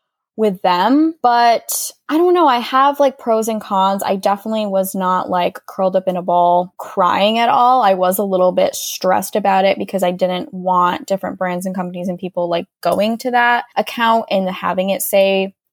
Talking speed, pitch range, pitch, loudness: 200 wpm, 185-225 Hz, 195 Hz, -16 LUFS